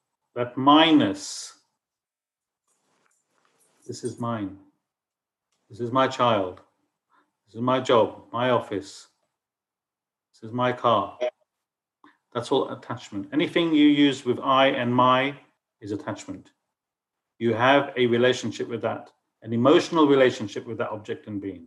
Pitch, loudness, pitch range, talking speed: 130 Hz, -23 LUFS, 120-145 Hz, 125 wpm